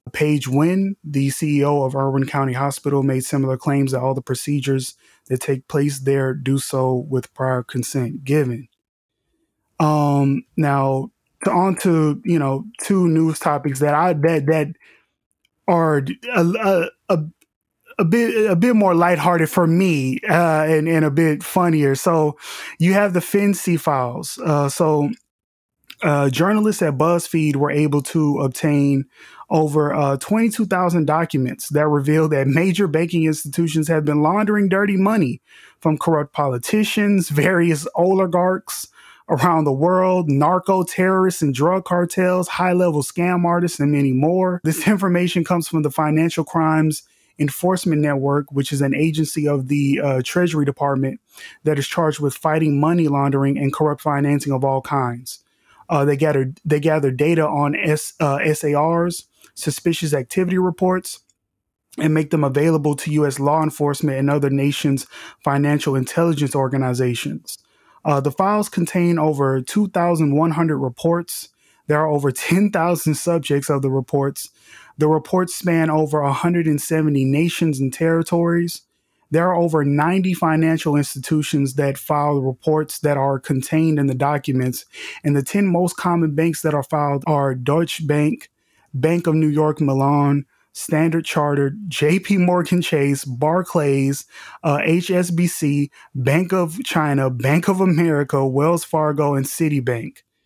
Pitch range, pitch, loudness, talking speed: 140-170 Hz, 155 Hz, -19 LUFS, 145 wpm